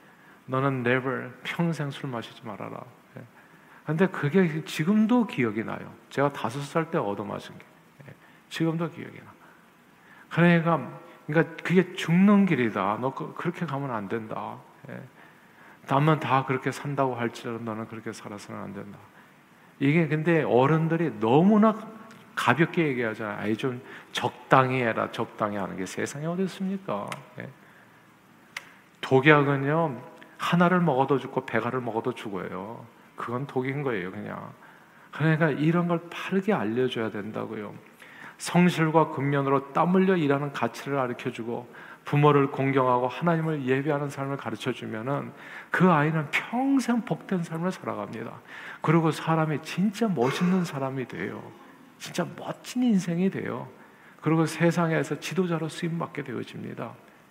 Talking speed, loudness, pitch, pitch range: 305 characters per minute, -26 LUFS, 150 Hz, 125-170 Hz